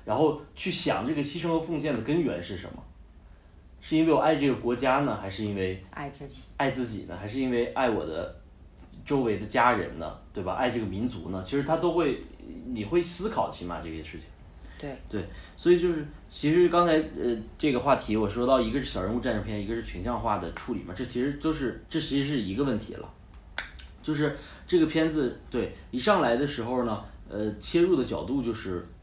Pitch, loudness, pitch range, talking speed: 120 Hz, -28 LUFS, 100-155 Hz, 305 characters per minute